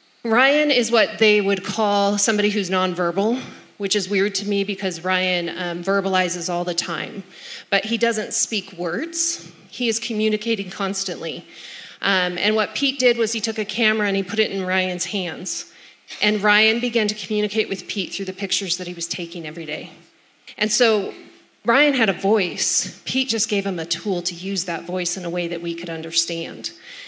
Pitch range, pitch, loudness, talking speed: 180-220 Hz, 200 Hz, -21 LUFS, 190 wpm